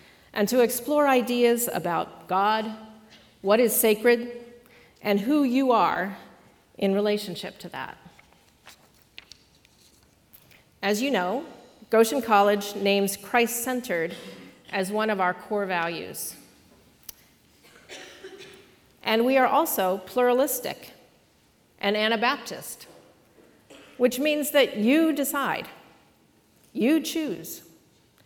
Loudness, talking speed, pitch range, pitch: -24 LUFS, 95 wpm, 205-260 Hz, 235 Hz